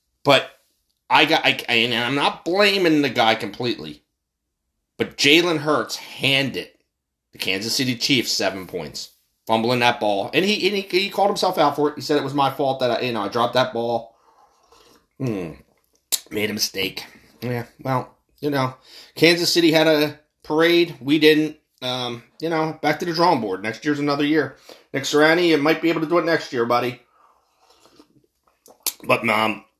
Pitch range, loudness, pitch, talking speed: 115-160 Hz, -20 LUFS, 135 Hz, 180 wpm